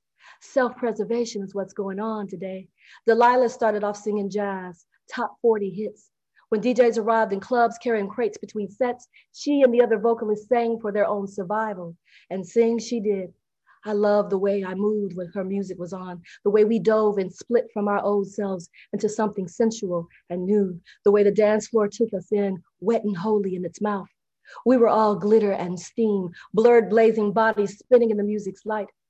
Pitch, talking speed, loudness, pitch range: 210 Hz, 190 wpm, -23 LUFS, 195-225 Hz